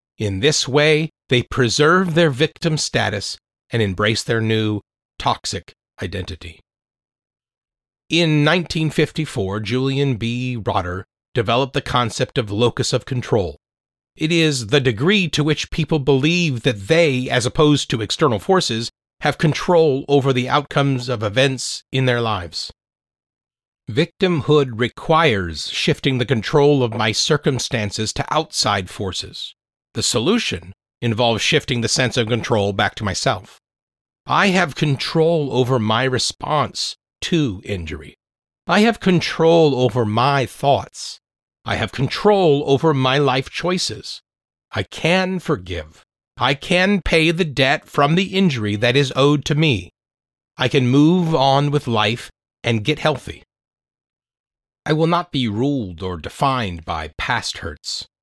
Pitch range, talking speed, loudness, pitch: 115-155 Hz, 135 wpm, -18 LUFS, 135 Hz